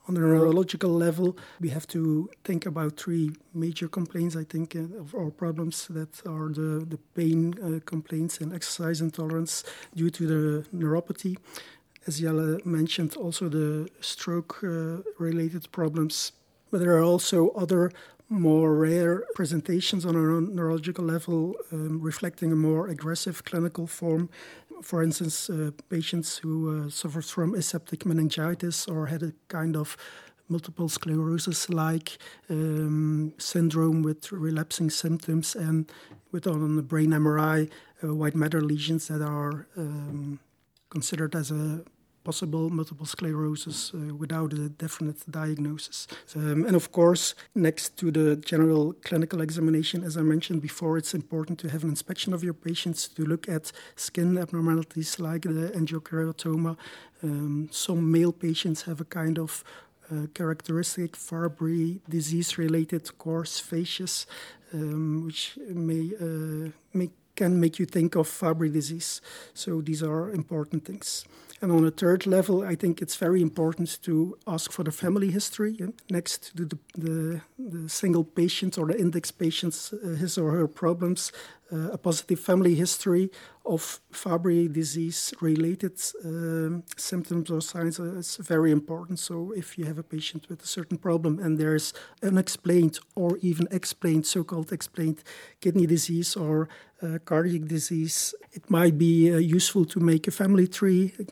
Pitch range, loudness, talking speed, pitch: 160-175 Hz, -28 LUFS, 145 wpm, 165 Hz